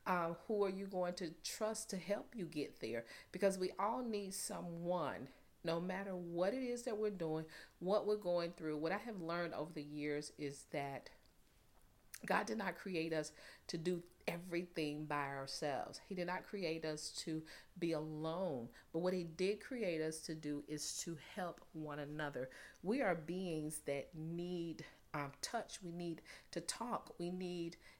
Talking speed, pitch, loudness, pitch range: 175 wpm, 170 Hz, -43 LUFS, 155-185 Hz